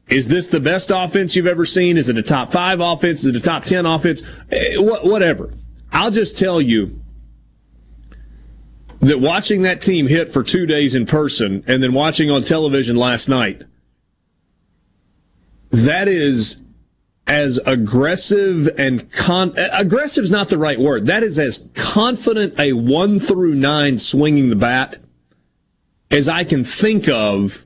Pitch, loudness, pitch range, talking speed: 145 Hz, -16 LUFS, 120-180 Hz, 150 wpm